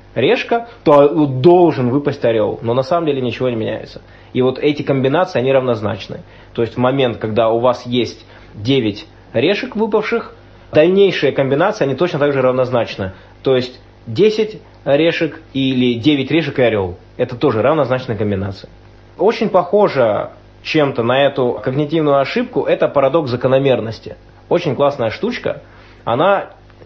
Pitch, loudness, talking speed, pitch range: 130 Hz, -16 LUFS, 140 wpm, 115-150 Hz